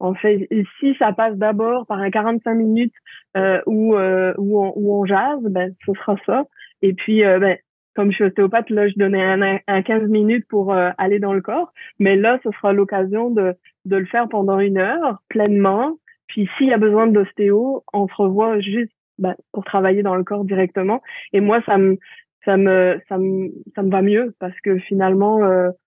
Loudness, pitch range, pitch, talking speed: -18 LUFS, 195-220 Hz, 200 Hz, 210 wpm